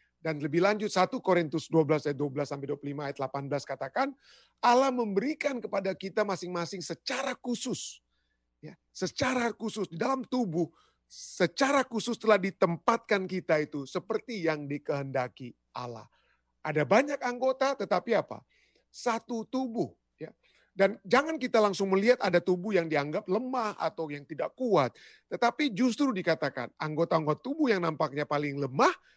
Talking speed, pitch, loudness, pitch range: 140 wpm, 190 Hz, -30 LUFS, 155-240 Hz